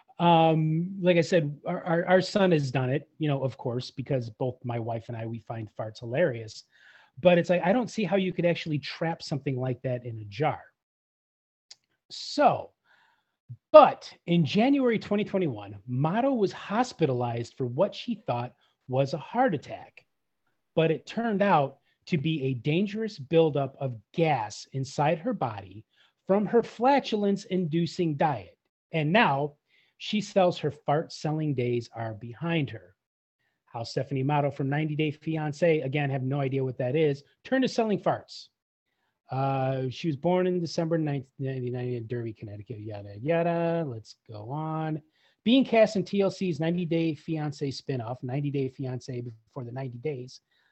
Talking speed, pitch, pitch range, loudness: 160 wpm, 150 Hz, 130-175 Hz, -27 LUFS